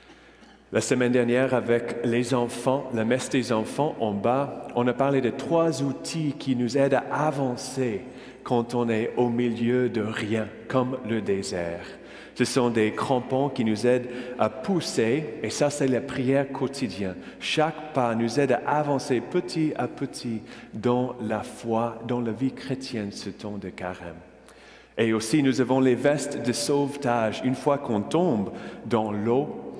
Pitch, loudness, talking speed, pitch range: 125 Hz, -26 LUFS, 165 wpm, 115-135 Hz